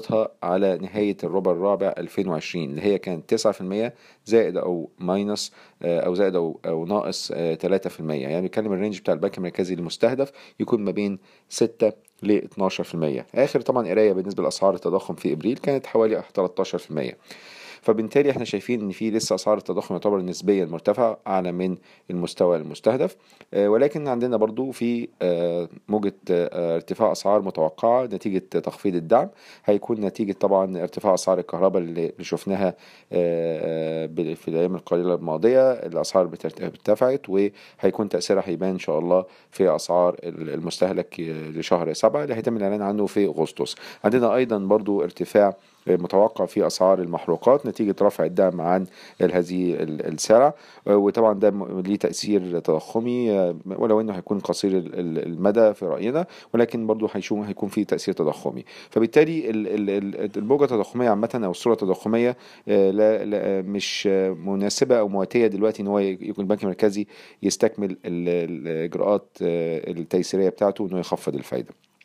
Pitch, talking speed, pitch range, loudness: 100 Hz, 130 wpm, 90-110 Hz, -23 LUFS